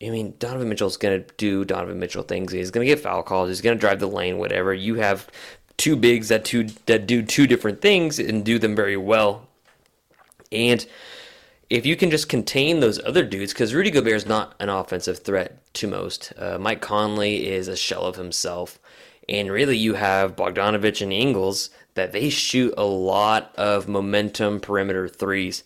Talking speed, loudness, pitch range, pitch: 190 wpm, -22 LUFS, 95-115 Hz, 105 Hz